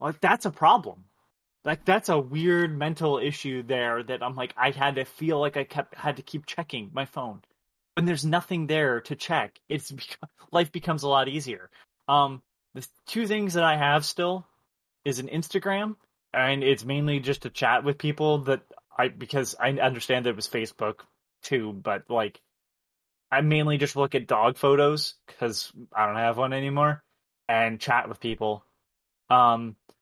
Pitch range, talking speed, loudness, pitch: 120-155 Hz, 175 wpm, -26 LUFS, 140 Hz